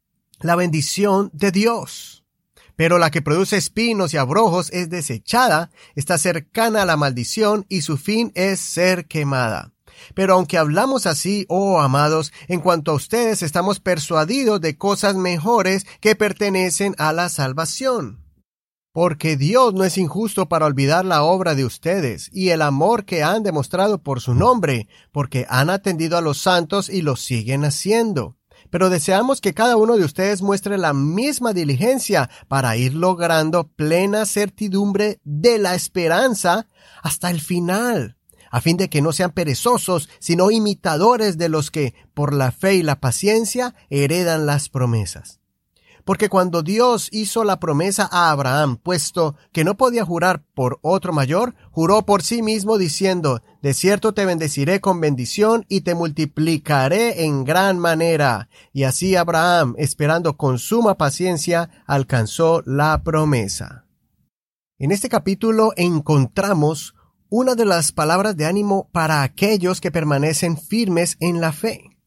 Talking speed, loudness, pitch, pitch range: 150 wpm, -18 LUFS, 175 Hz, 150-200 Hz